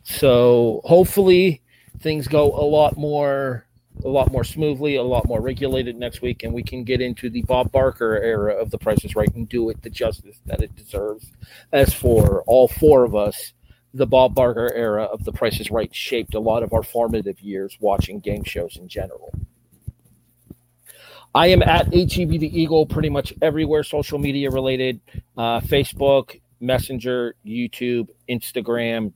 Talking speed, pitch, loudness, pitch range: 175 wpm, 125 Hz, -20 LUFS, 115-140 Hz